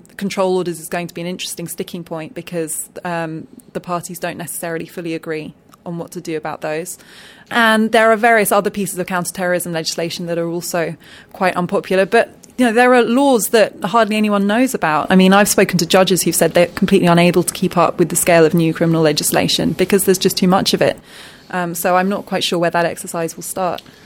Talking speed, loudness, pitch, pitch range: 220 wpm, -16 LUFS, 180 Hz, 170-200 Hz